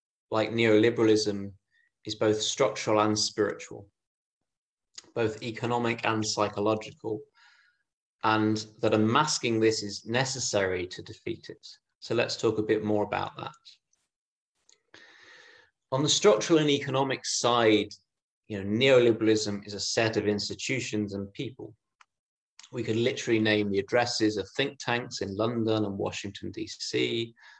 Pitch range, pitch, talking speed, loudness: 105-120 Hz, 110 Hz, 125 wpm, -27 LUFS